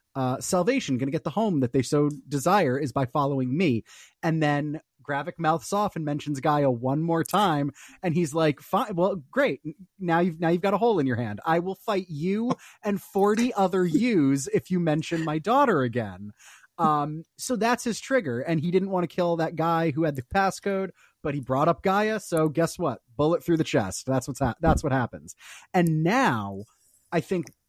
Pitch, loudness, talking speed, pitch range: 160 Hz, -25 LUFS, 205 wpm, 140-185 Hz